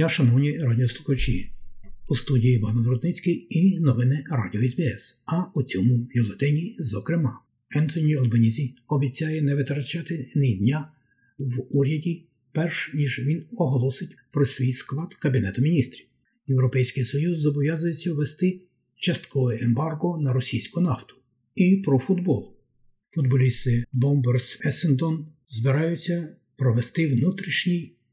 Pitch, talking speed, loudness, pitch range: 140 Hz, 105 wpm, -24 LUFS, 125-165 Hz